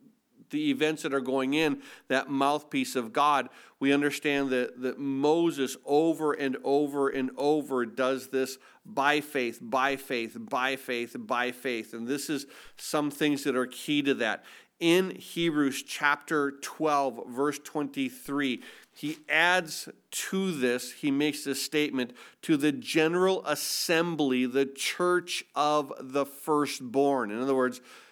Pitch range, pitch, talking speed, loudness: 130-150 Hz, 140 Hz, 140 wpm, -29 LUFS